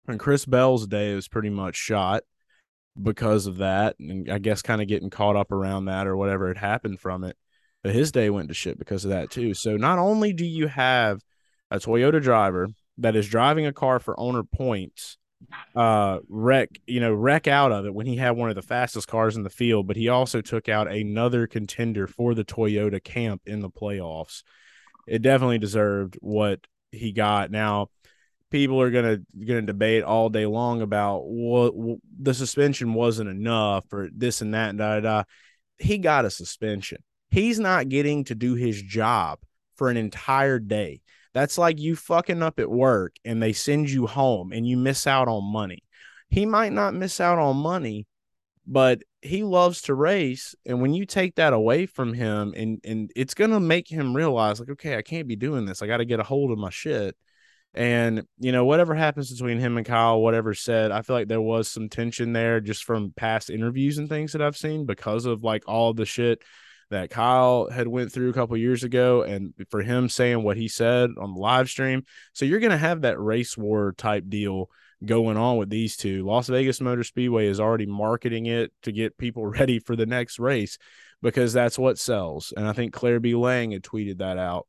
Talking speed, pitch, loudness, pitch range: 205 wpm, 115 Hz, -24 LUFS, 105-130 Hz